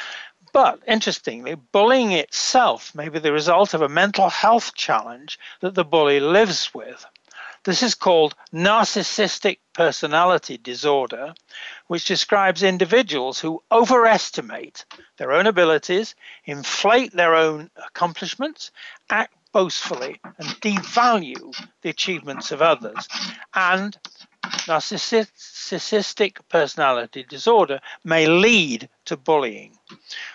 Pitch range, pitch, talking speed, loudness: 160-220 Hz, 190 Hz, 105 wpm, -19 LUFS